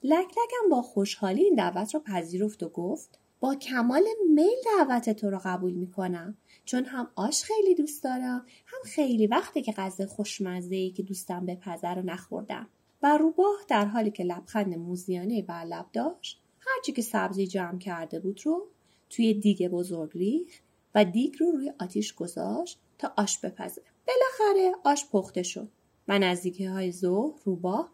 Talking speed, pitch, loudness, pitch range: 165 wpm, 215 Hz, -28 LUFS, 185-305 Hz